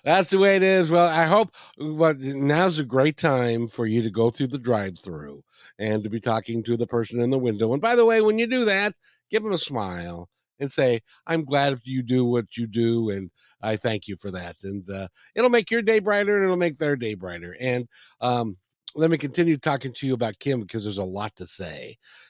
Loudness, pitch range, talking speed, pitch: -23 LUFS, 110-165 Hz, 235 wpm, 125 Hz